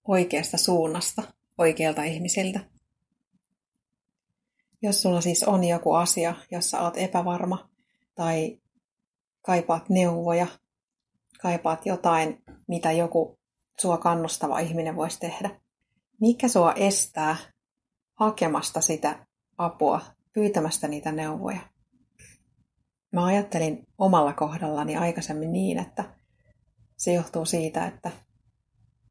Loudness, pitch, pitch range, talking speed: -25 LUFS, 170 Hz, 160-195 Hz, 95 wpm